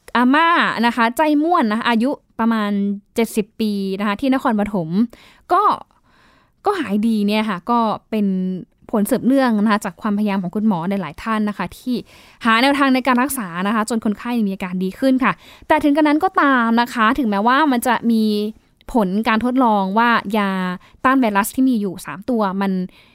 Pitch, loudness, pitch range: 225 Hz, -18 LUFS, 205-255 Hz